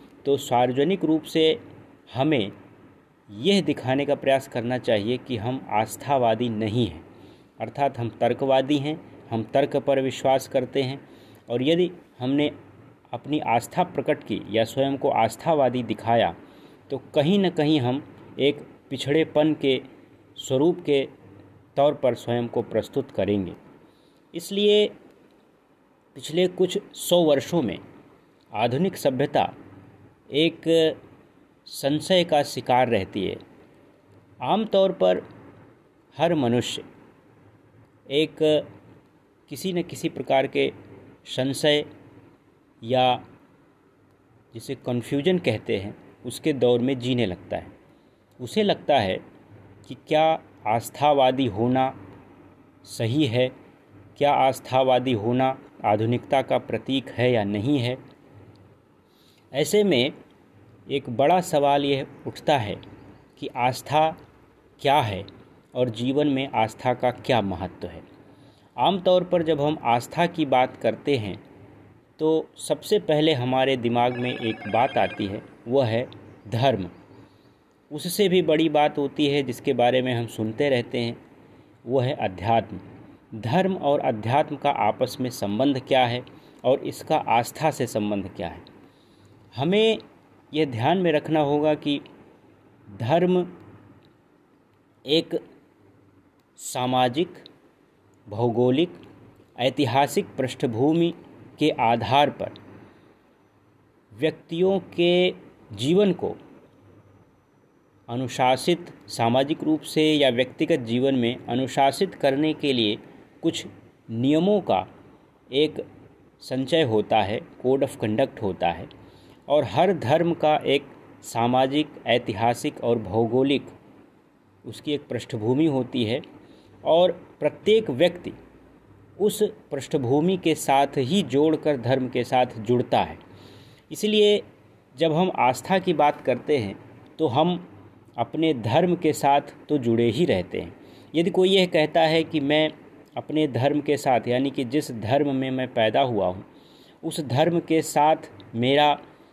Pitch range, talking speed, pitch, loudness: 120-155 Hz, 120 wpm, 135 Hz, -23 LUFS